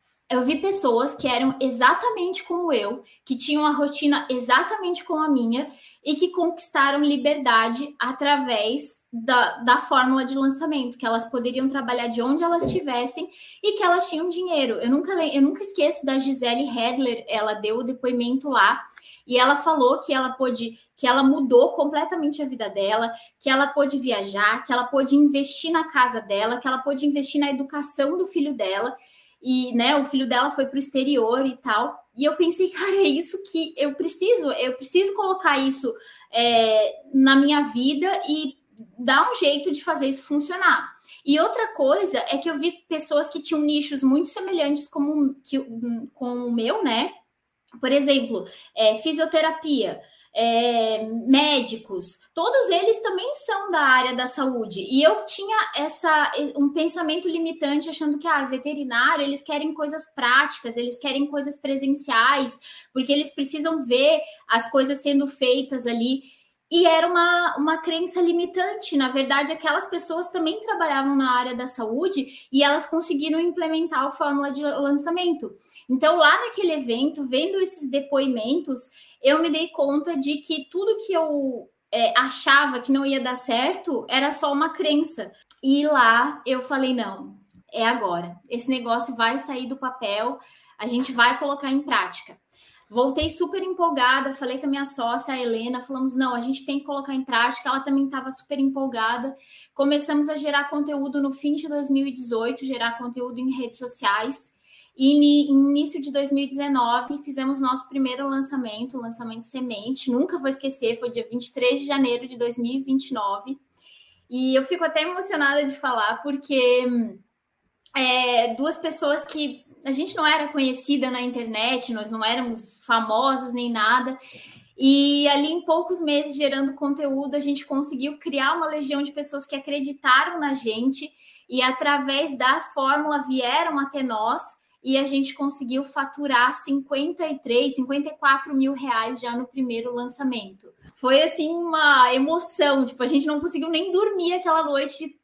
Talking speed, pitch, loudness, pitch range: 160 wpm, 275 Hz, -22 LUFS, 255-310 Hz